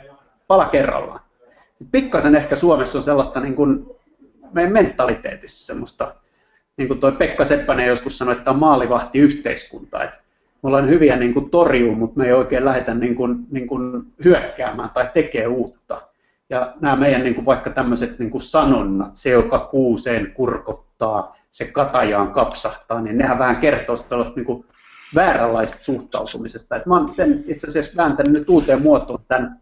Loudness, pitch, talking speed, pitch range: -18 LUFS, 135 Hz, 155 wpm, 125-155 Hz